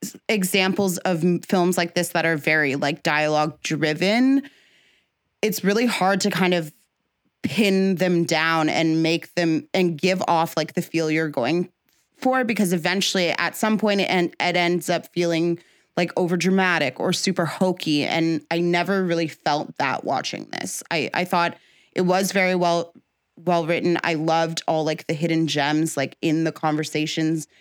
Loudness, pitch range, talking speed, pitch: -22 LUFS, 160-185 Hz, 165 wpm, 175 Hz